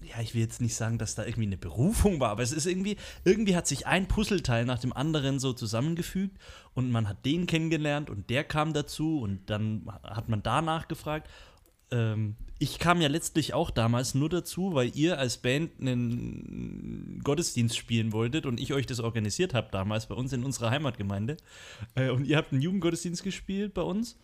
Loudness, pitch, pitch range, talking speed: -30 LUFS, 130 Hz, 115-160 Hz, 195 wpm